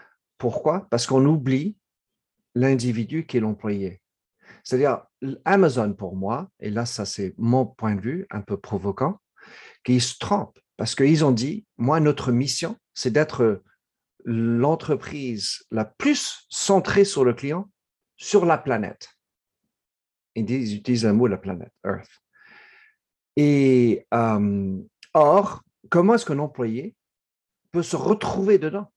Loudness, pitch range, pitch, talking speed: -23 LUFS, 110-170 Hz, 130 Hz, 135 wpm